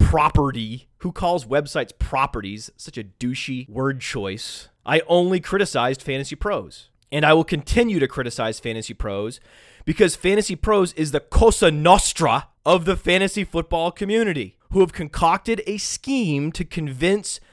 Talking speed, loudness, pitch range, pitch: 145 wpm, -21 LUFS, 130-185 Hz, 155 Hz